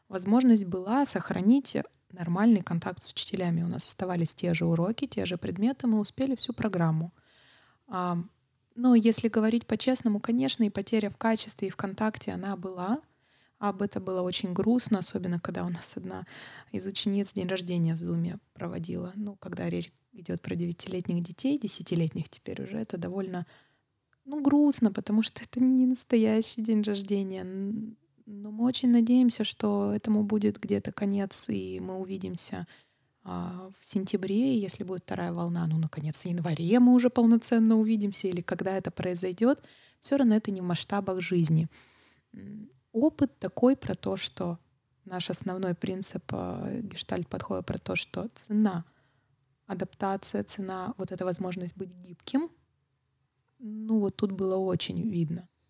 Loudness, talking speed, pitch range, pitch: -28 LUFS, 150 wpm, 180-225 Hz, 195 Hz